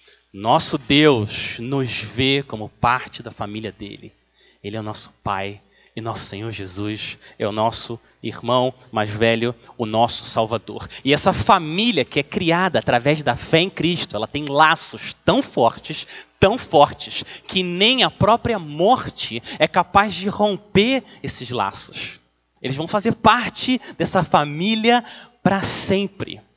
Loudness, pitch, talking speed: -20 LUFS, 140 Hz, 145 wpm